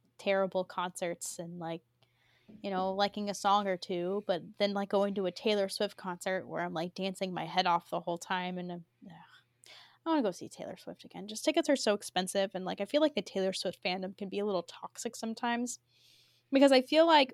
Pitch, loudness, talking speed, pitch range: 190 Hz, -32 LUFS, 230 wpm, 180-205 Hz